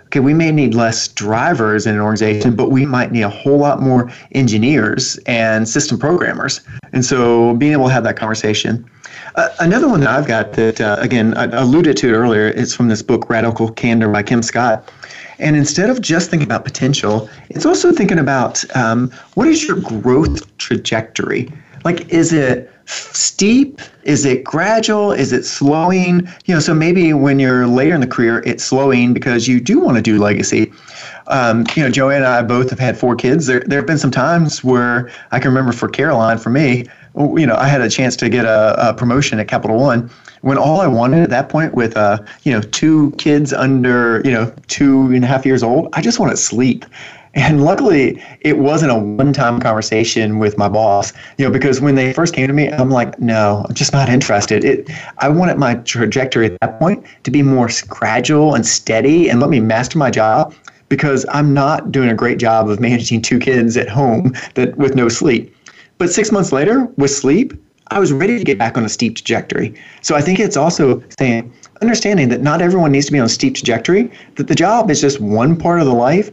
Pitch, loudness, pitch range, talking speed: 130 Hz, -14 LUFS, 115-145 Hz, 215 wpm